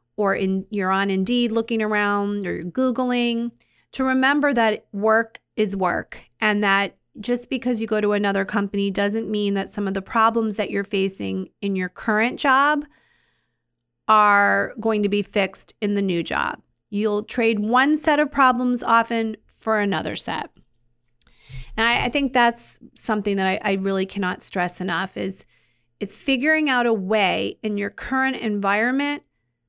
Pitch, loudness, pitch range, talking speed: 210 Hz, -21 LUFS, 195-235 Hz, 165 wpm